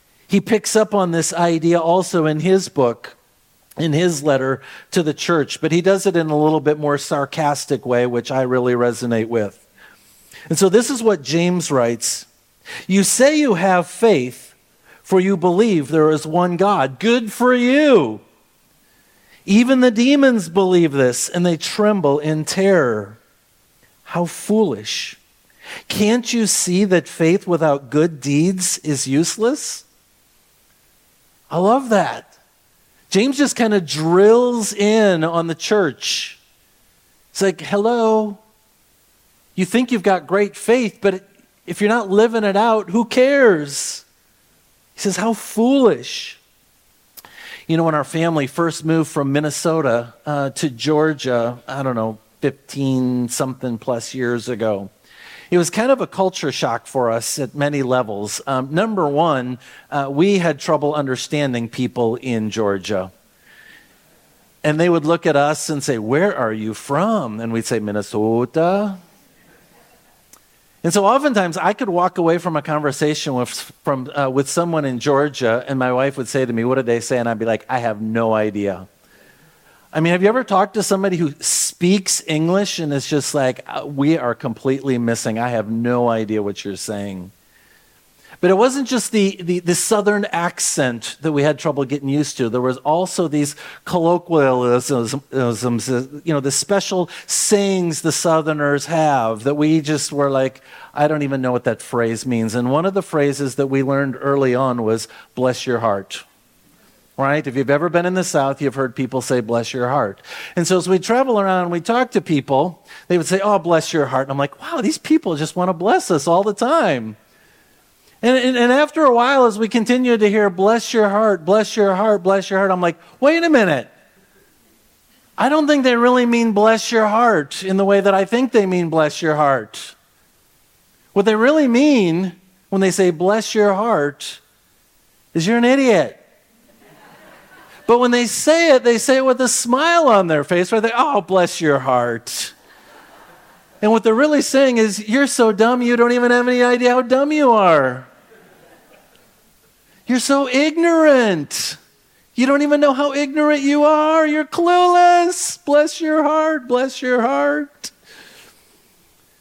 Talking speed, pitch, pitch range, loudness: 170 wpm, 170 Hz, 140-215 Hz, -17 LUFS